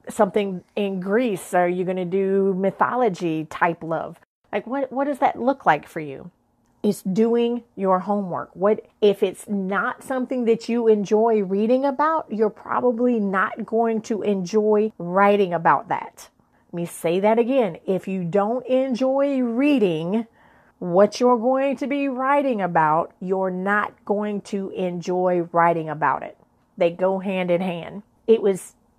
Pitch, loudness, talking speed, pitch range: 205 Hz, -22 LUFS, 155 wpm, 185-235 Hz